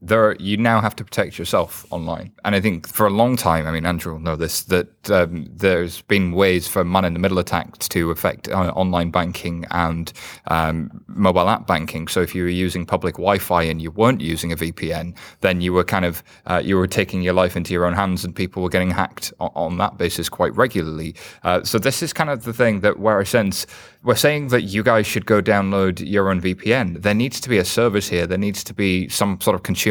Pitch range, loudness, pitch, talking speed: 85-105 Hz, -20 LUFS, 95 Hz, 235 wpm